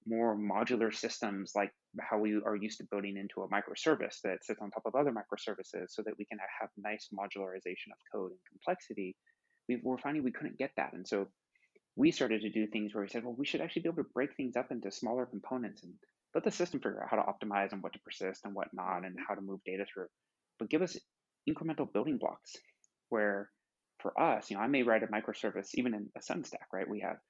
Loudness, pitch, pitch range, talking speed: -37 LUFS, 105 Hz, 100-120 Hz, 235 wpm